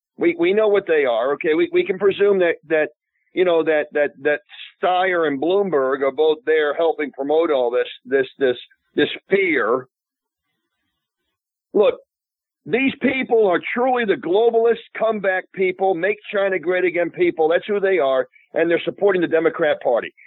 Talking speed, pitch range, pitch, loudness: 165 wpm, 160-240 Hz, 190 Hz, -19 LUFS